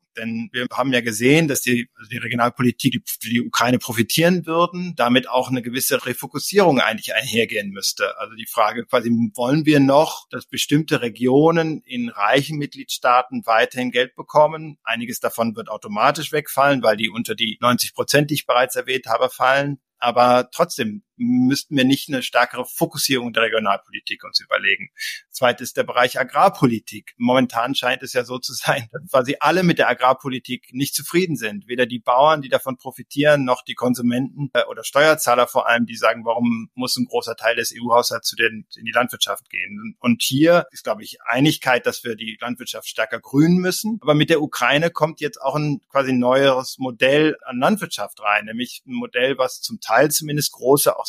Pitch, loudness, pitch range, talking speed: 130 Hz, -19 LUFS, 120-155 Hz, 175 wpm